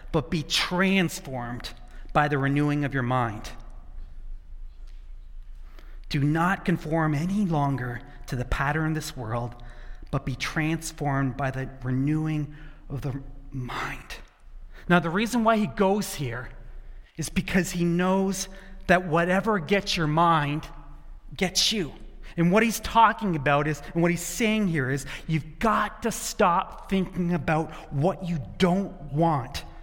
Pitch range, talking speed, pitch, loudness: 135-185 Hz, 140 wpm, 155 Hz, -26 LUFS